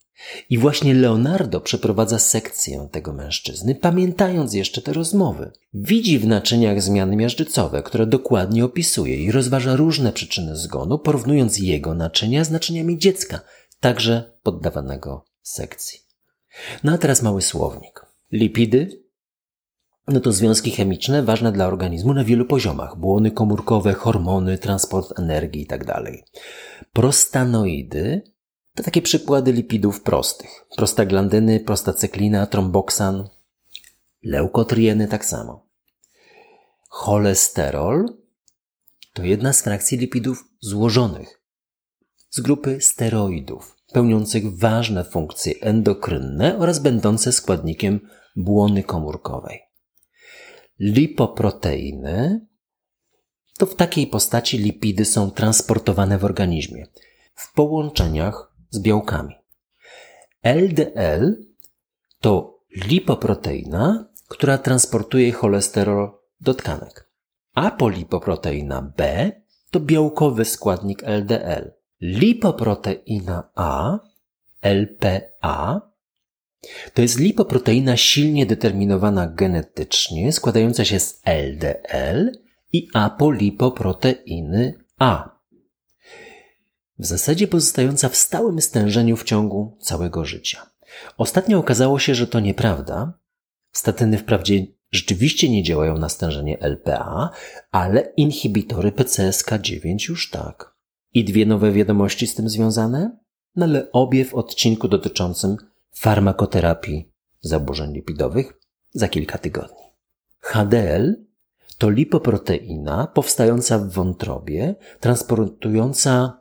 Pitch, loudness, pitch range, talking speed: 110 Hz, -19 LUFS, 100-135 Hz, 95 wpm